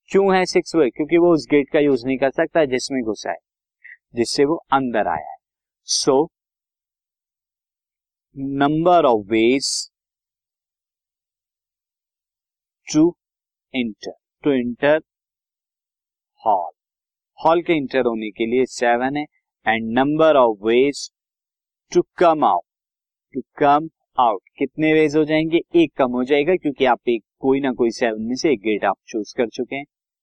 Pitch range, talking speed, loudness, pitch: 125-160 Hz, 145 wpm, -19 LUFS, 140 Hz